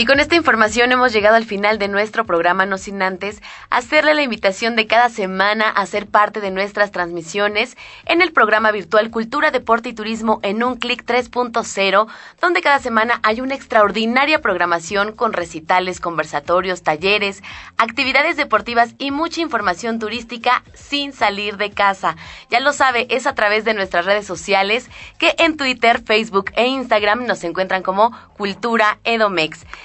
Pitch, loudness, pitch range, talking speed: 220 Hz, -17 LUFS, 200-245 Hz, 160 wpm